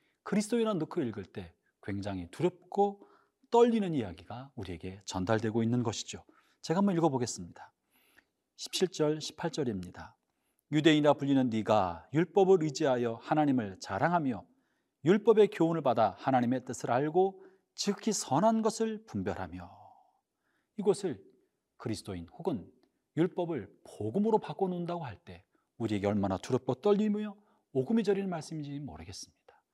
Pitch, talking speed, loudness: 150 Hz, 315 characters per minute, -31 LUFS